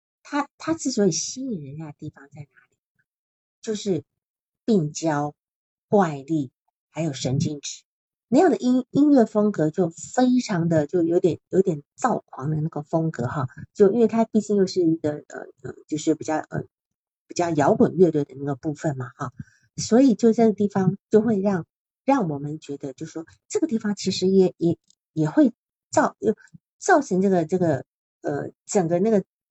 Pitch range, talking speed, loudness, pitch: 150-210 Hz, 245 characters per minute, -23 LUFS, 170 Hz